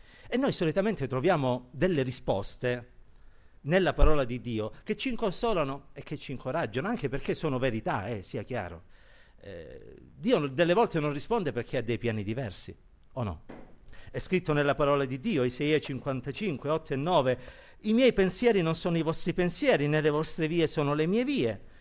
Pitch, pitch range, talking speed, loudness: 150 Hz, 130-180 Hz, 175 wpm, -29 LUFS